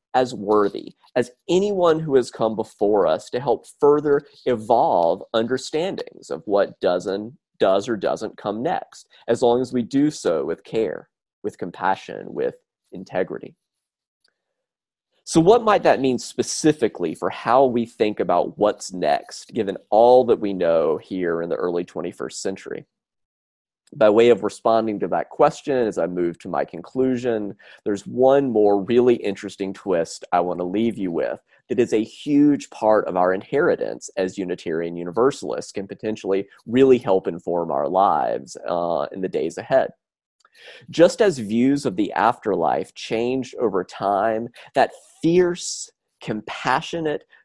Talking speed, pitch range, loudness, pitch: 150 wpm, 100-140 Hz, -21 LUFS, 120 Hz